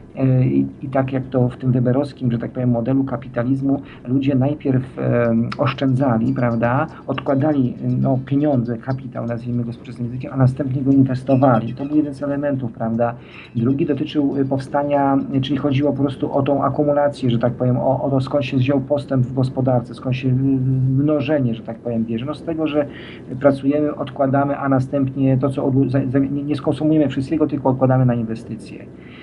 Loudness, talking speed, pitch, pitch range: -19 LUFS, 170 wpm, 135 Hz, 125-140 Hz